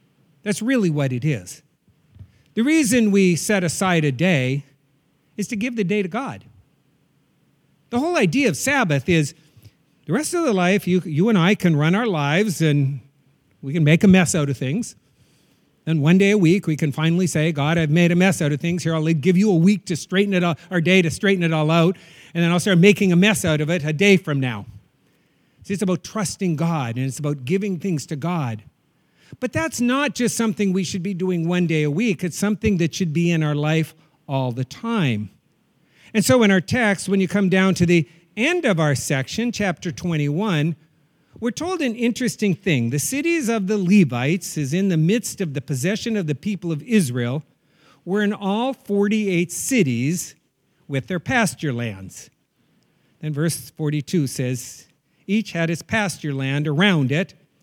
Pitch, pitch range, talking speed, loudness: 175 Hz, 150-200 Hz, 200 wpm, -20 LUFS